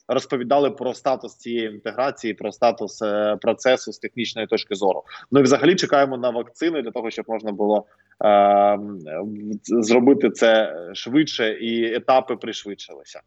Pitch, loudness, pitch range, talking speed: 115 Hz, -21 LUFS, 105-130 Hz, 140 wpm